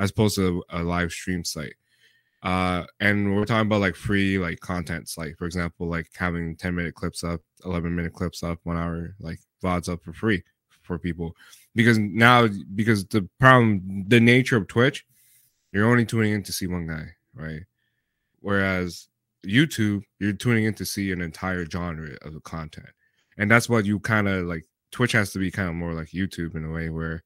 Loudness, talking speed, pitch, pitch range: -24 LUFS, 200 wpm, 95 Hz, 85-110 Hz